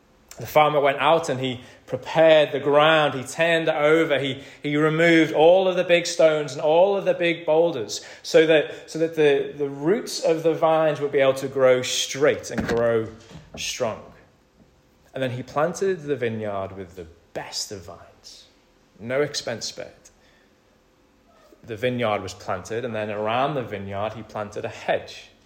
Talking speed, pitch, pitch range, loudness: 170 wpm, 145 Hz, 120-160 Hz, -22 LUFS